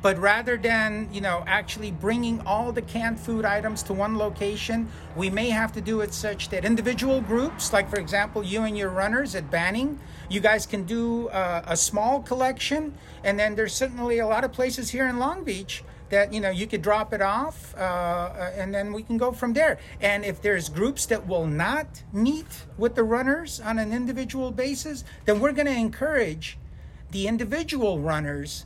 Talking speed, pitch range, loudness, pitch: 195 wpm, 200-245 Hz, -26 LUFS, 220 Hz